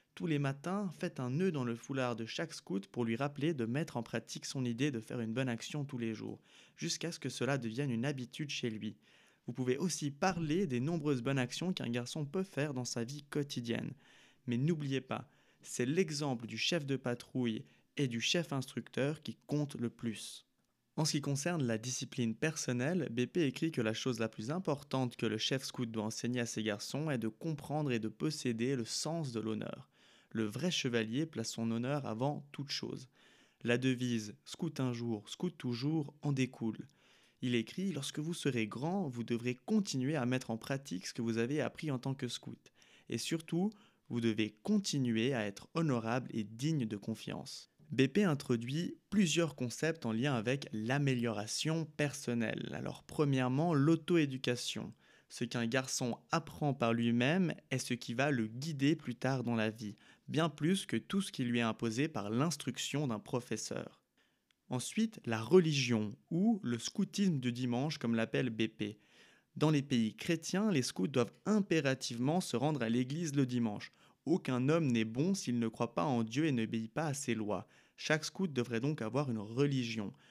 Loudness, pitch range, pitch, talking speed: -36 LUFS, 115-155 Hz, 130 Hz, 185 wpm